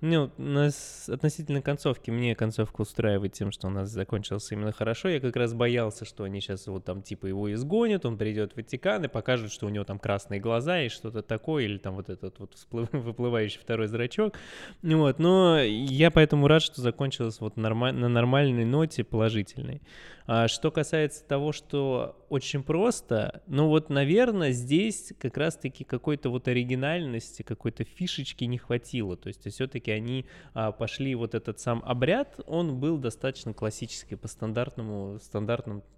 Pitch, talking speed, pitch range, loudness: 120 Hz, 170 wpm, 110-145 Hz, -28 LUFS